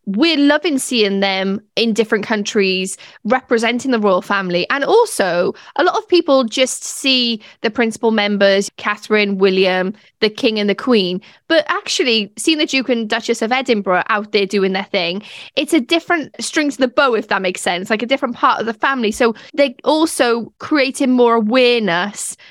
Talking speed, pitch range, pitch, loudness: 180 wpm, 205-270 Hz, 230 Hz, -16 LUFS